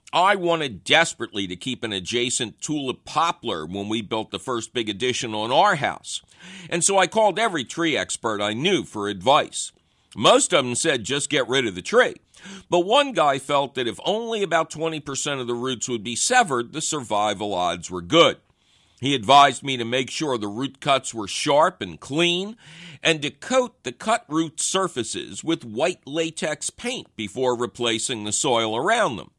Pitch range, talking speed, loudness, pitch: 120-170 Hz, 185 wpm, -22 LUFS, 140 Hz